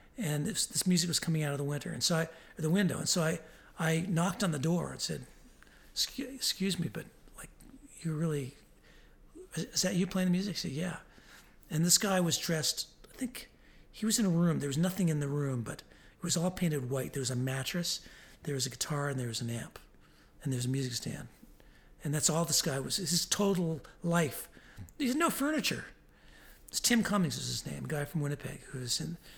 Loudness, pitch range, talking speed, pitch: -32 LUFS, 145-185 Hz, 225 wpm, 165 Hz